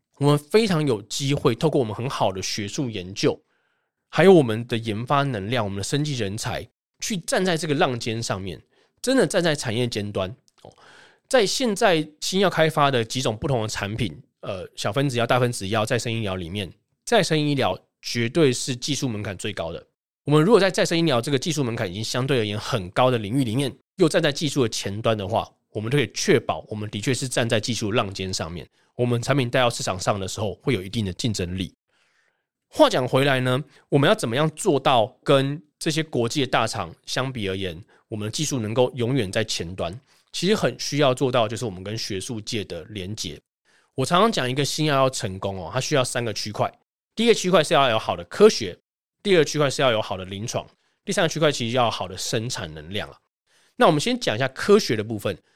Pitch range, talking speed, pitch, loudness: 110-145 Hz, 325 characters per minute, 125 Hz, -23 LUFS